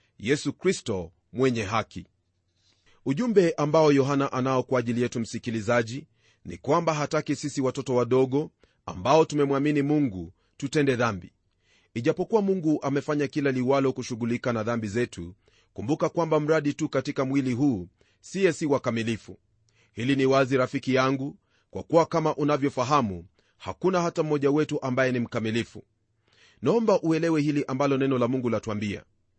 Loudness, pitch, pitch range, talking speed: -26 LUFS, 130 Hz, 110-150 Hz, 135 wpm